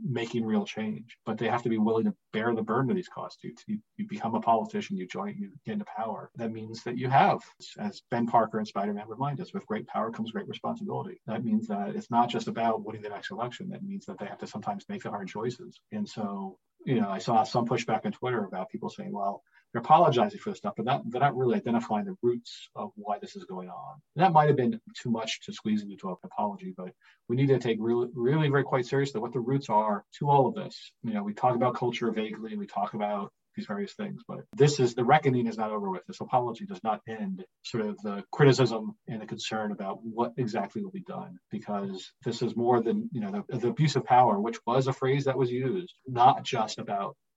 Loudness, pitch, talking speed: -29 LUFS, 125 Hz, 245 wpm